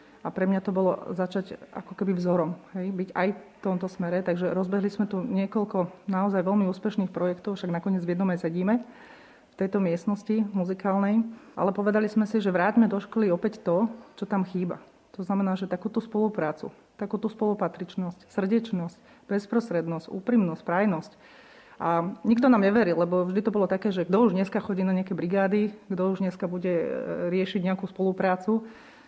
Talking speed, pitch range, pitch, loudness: 170 wpm, 185-215 Hz, 195 Hz, -27 LUFS